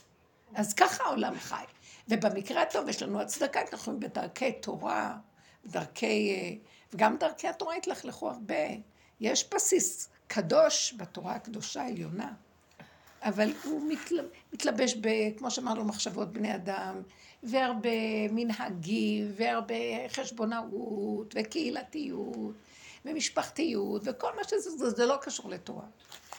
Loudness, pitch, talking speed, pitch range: -32 LUFS, 235 Hz, 105 wpm, 215-300 Hz